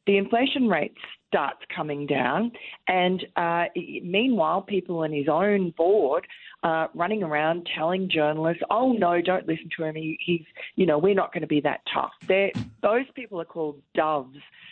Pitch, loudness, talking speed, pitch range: 175 Hz, -25 LUFS, 175 wpm, 160-200 Hz